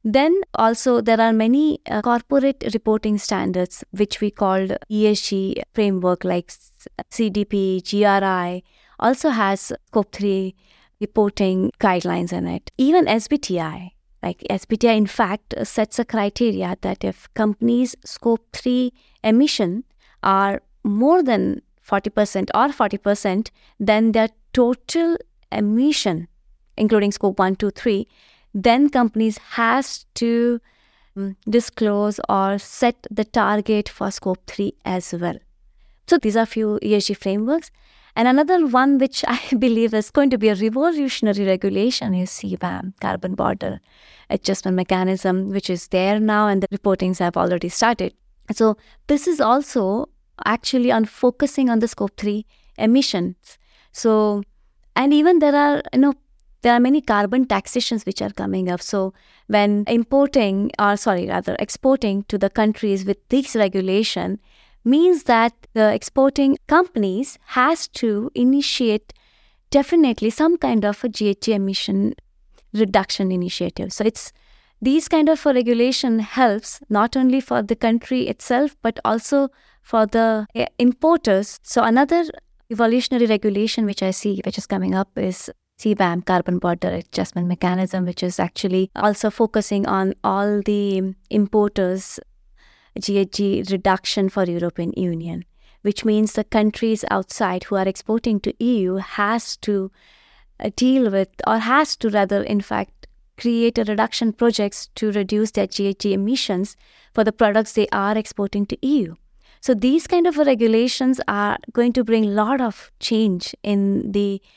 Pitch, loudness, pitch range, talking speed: 215 Hz, -20 LUFS, 195-245 Hz, 140 wpm